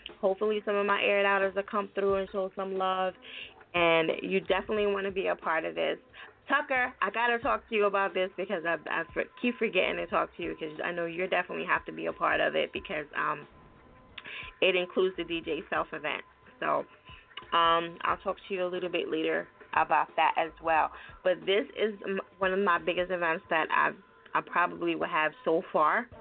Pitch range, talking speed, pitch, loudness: 180-205 Hz, 210 wpm, 195 Hz, -29 LUFS